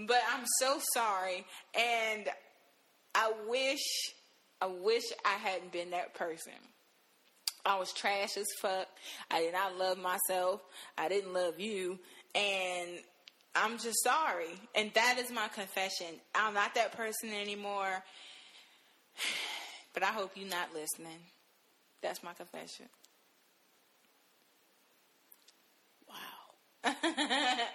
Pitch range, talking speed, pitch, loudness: 185-230 Hz, 110 wpm, 200 Hz, -35 LUFS